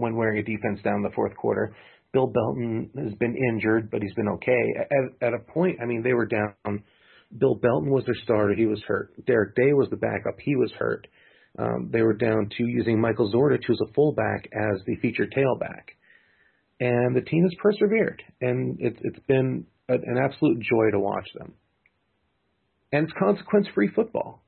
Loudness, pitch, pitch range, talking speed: -25 LUFS, 120 Hz, 110-135 Hz, 195 wpm